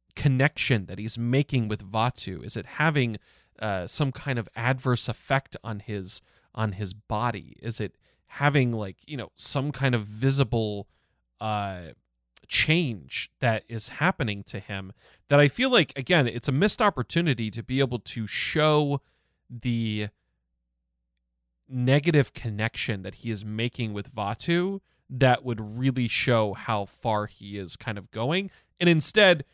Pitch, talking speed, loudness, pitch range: 115 Hz, 150 wpm, -25 LUFS, 105-140 Hz